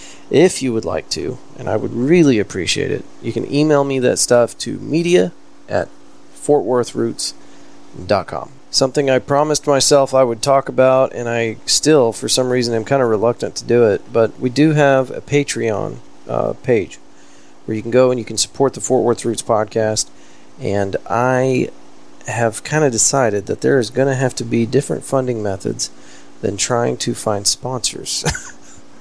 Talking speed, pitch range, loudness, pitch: 175 wpm, 115-135 Hz, -17 LUFS, 125 Hz